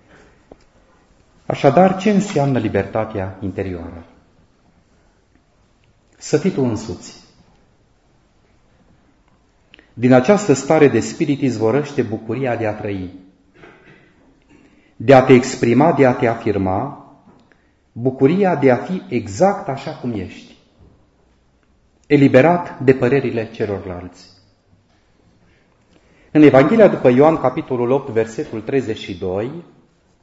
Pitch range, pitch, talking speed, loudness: 100-140 Hz, 120 Hz, 95 wpm, -16 LUFS